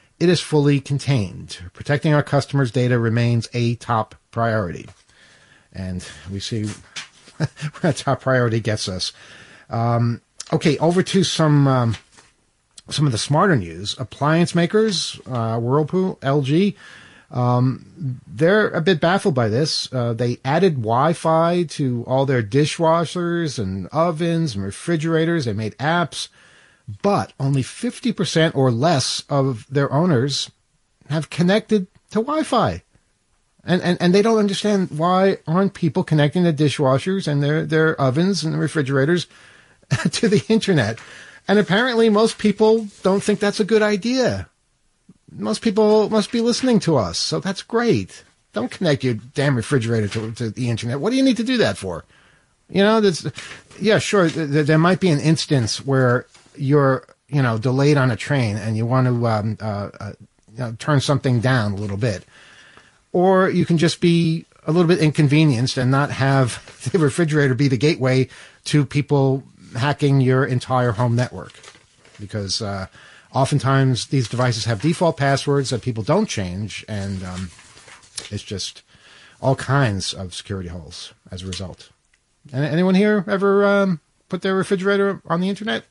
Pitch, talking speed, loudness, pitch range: 145 Hz, 155 wpm, -19 LUFS, 120-175 Hz